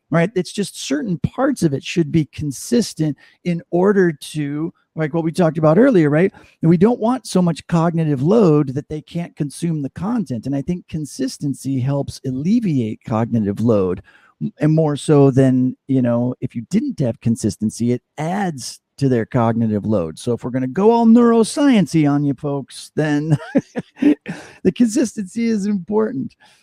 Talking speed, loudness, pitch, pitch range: 170 wpm, -18 LUFS, 155 Hz, 130-195 Hz